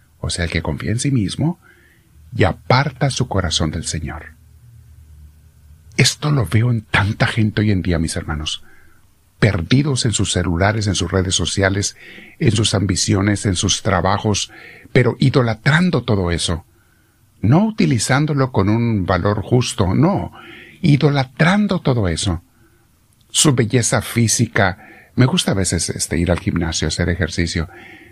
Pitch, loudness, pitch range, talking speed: 105 Hz, -17 LUFS, 90-125 Hz, 145 wpm